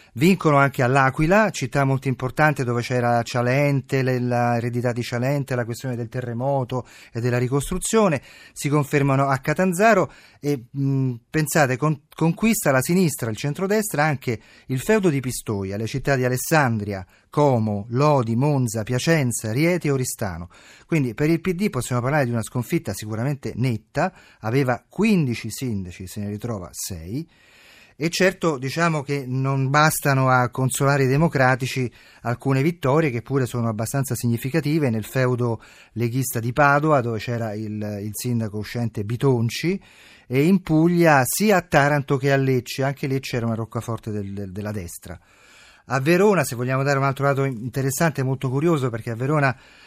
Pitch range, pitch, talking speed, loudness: 120-150 Hz, 130 Hz, 155 wpm, -22 LUFS